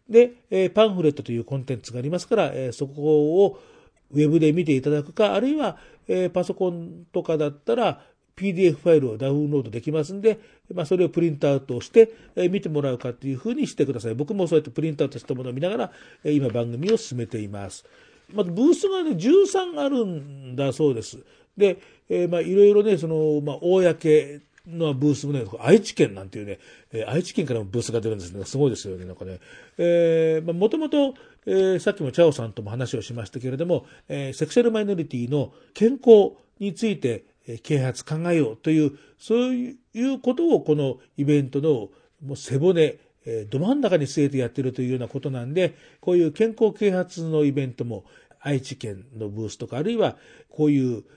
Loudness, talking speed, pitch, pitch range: -23 LUFS, 375 characters per minute, 150 Hz, 130-190 Hz